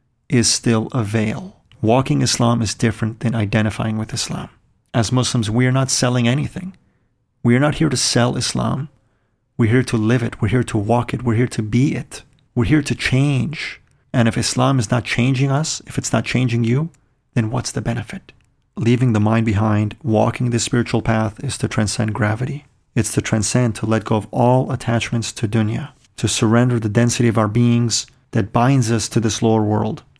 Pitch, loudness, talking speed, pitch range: 120 Hz, -18 LUFS, 195 wpm, 110-130 Hz